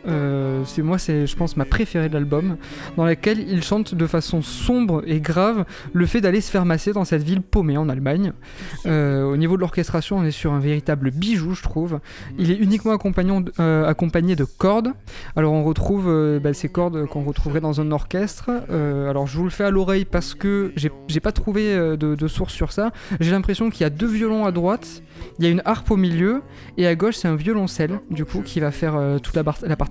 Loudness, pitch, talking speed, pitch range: -21 LUFS, 170 Hz, 235 wpm, 150-195 Hz